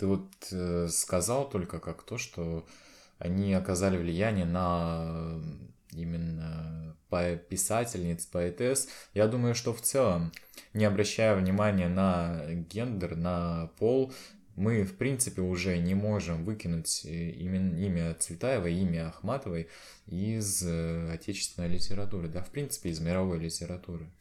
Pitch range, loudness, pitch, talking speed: 85-105 Hz, -31 LUFS, 90 Hz, 120 wpm